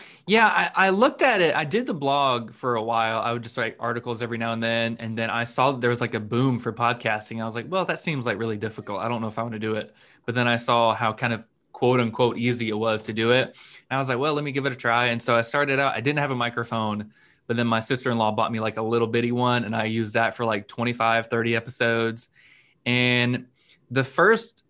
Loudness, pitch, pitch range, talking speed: -24 LUFS, 120 Hz, 115-130 Hz, 275 wpm